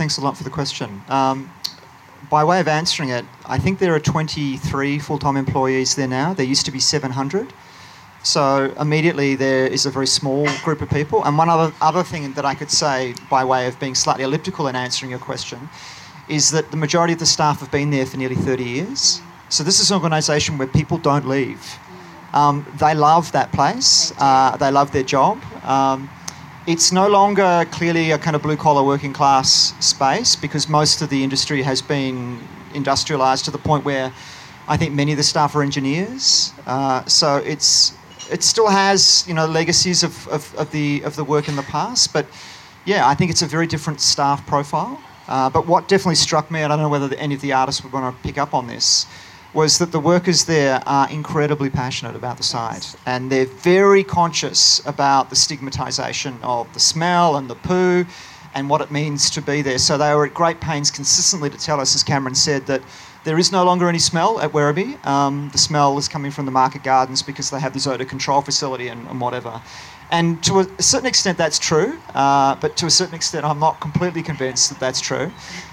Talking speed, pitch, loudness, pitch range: 210 wpm, 145 Hz, -17 LUFS, 135-160 Hz